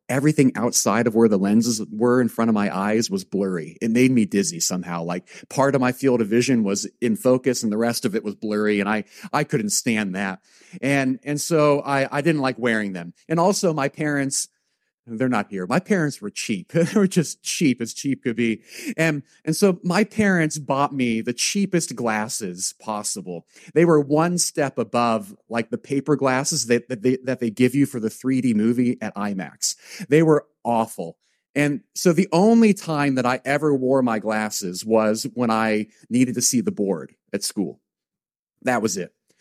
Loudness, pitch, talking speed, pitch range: -21 LUFS, 125 Hz, 200 wpm, 110-150 Hz